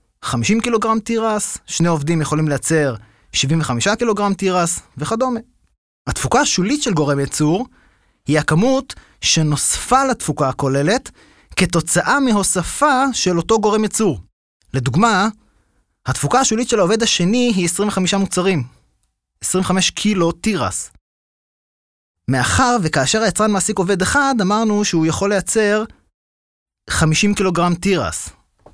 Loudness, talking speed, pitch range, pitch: -17 LUFS, 110 wpm, 150-220 Hz, 185 Hz